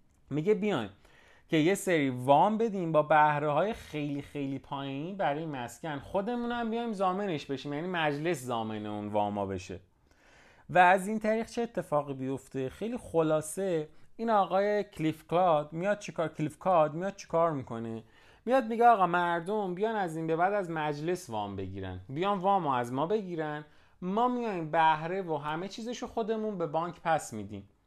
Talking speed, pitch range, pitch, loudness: 165 wpm, 140-200 Hz, 160 Hz, -30 LUFS